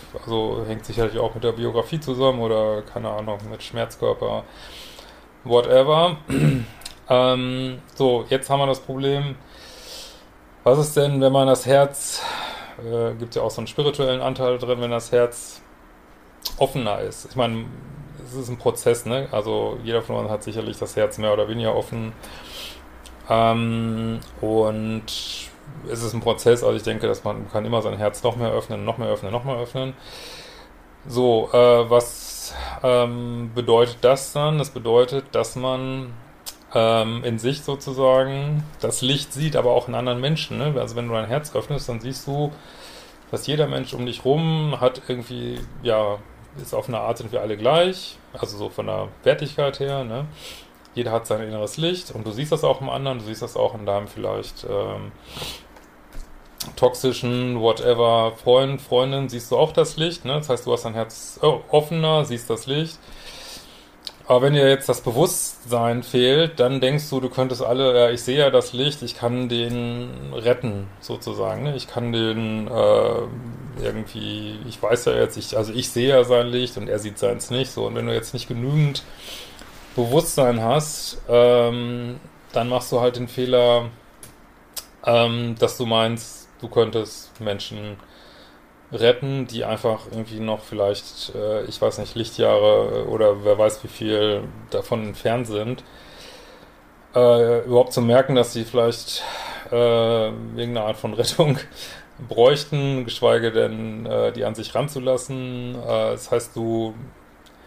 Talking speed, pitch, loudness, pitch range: 165 wpm, 120 Hz, -22 LUFS, 110-135 Hz